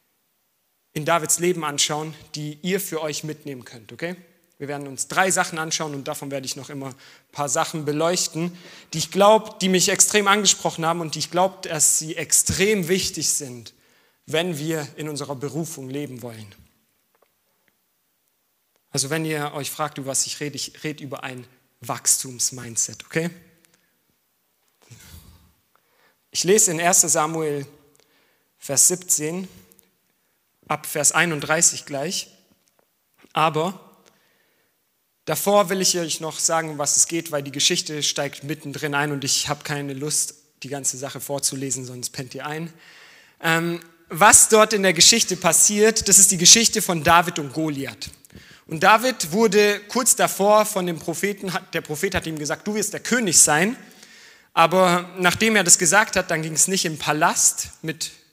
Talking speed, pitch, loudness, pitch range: 155 wpm, 160 Hz, -19 LUFS, 145-180 Hz